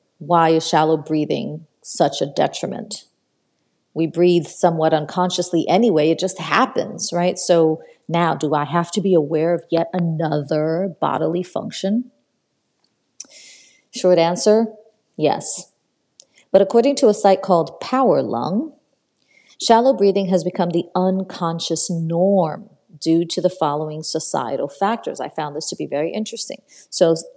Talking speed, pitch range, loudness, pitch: 135 wpm, 165-215 Hz, -19 LUFS, 180 Hz